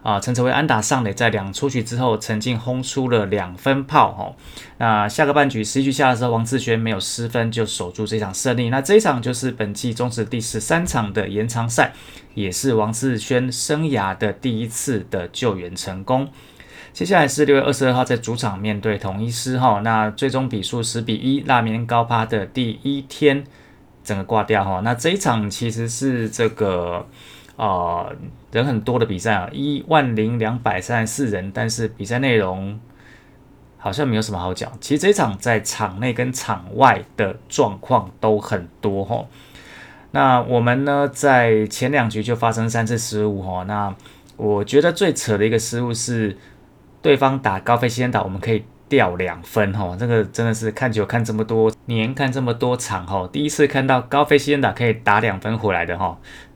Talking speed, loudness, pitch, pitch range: 280 characters per minute, -20 LUFS, 115 Hz, 105-130 Hz